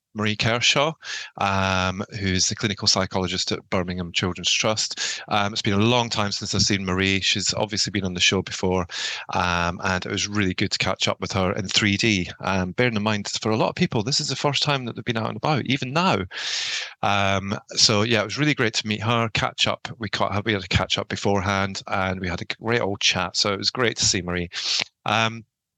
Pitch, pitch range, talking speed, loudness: 105 Hz, 95-115 Hz, 230 wpm, -22 LUFS